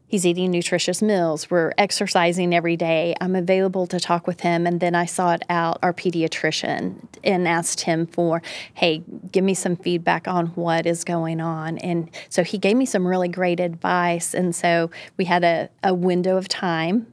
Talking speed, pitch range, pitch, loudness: 185 wpm, 170-185 Hz, 175 Hz, -21 LUFS